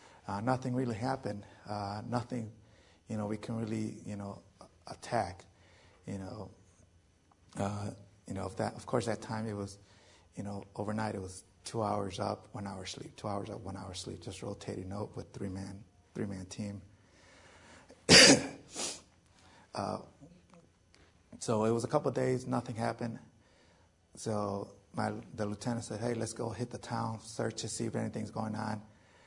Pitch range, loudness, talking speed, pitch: 95-115 Hz, -33 LUFS, 170 wpm, 105 Hz